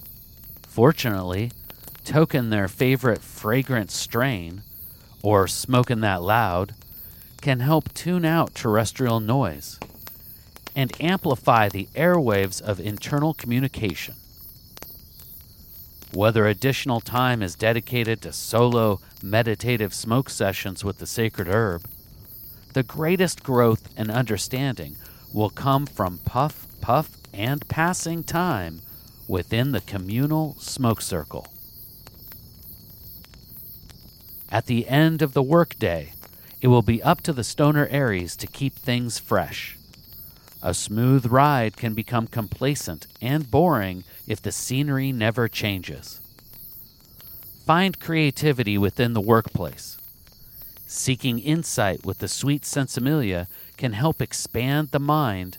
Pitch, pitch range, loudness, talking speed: 115 Hz, 105-135 Hz, -23 LUFS, 110 wpm